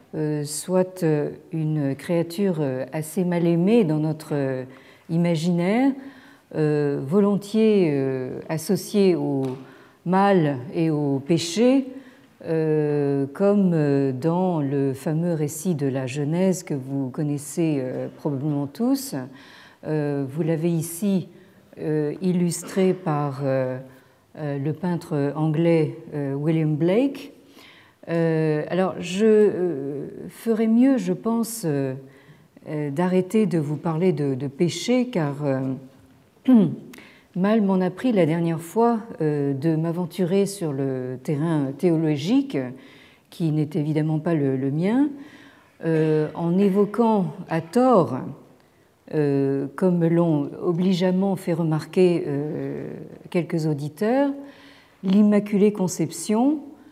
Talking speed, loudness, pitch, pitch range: 95 wpm, -23 LUFS, 165 Hz, 145-190 Hz